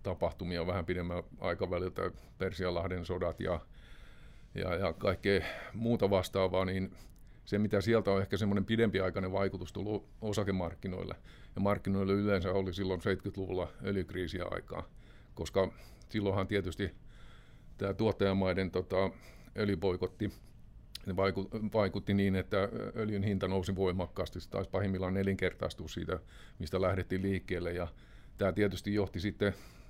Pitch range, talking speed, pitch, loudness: 90-100 Hz, 115 wpm, 95 Hz, -35 LUFS